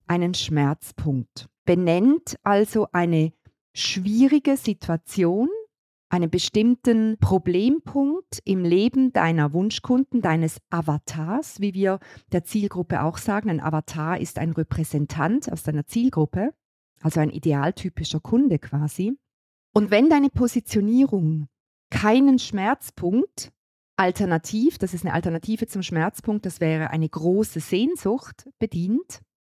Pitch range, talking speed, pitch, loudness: 160-225 Hz, 110 wpm, 185 Hz, -23 LUFS